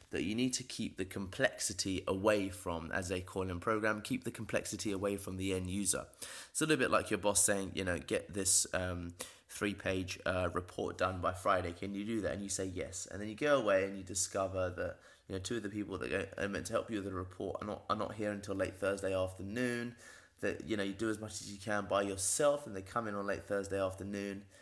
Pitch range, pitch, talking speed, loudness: 95-105 Hz, 100 Hz, 250 wpm, -36 LUFS